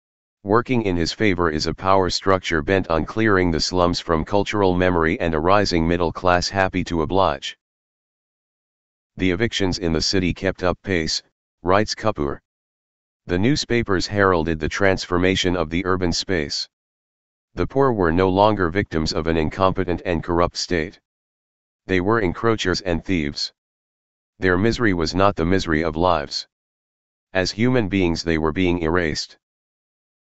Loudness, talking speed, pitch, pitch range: -20 LUFS, 150 wpm, 90 Hz, 80-95 Hz